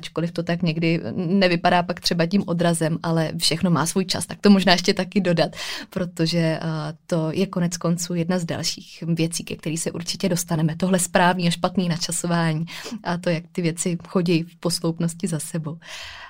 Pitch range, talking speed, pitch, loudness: 165-185 Hz, 180 wpm, 170 Hz, -22 LUFS